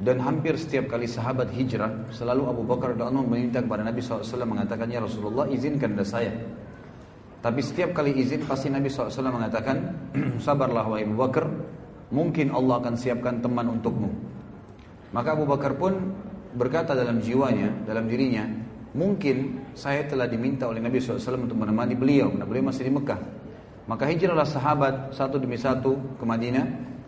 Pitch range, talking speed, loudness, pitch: 120-140 Hz, 155 wpm, -26 LUFS, 130 Hz